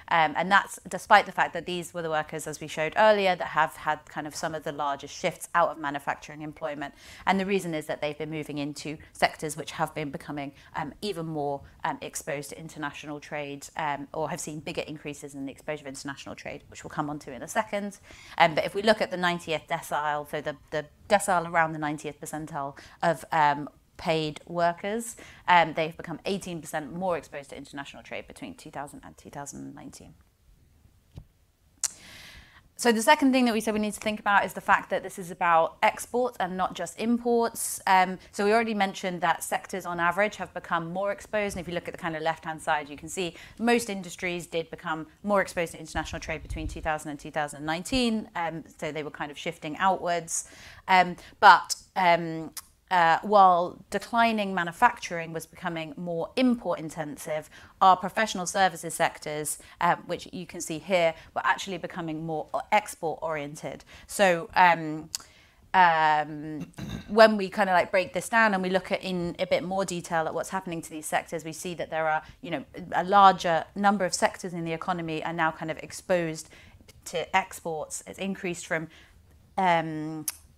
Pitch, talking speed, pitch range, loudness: 165 Hz, 190 wpm, 155-190 Hz, -27 LUFS